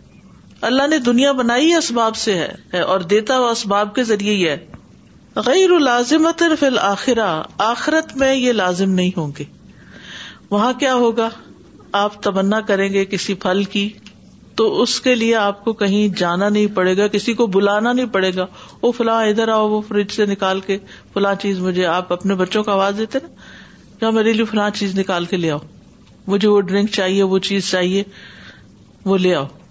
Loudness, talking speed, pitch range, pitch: -17 LUFS, 180 wpm, 195-230 Hz, 205 Hz